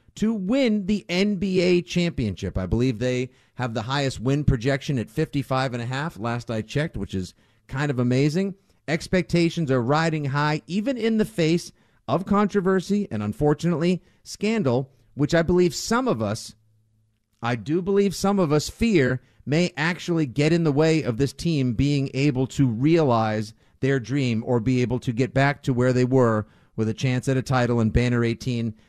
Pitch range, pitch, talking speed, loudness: 120-170 Hz, 135 Hz, 170 wpm, -23 LUFS